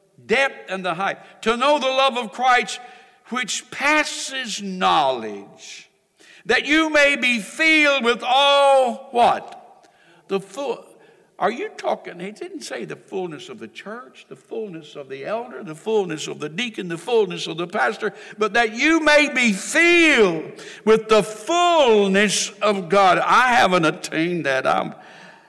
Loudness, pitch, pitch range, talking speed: -19 LUFS, 235 Hz, 195-285 Hz, 155 wpm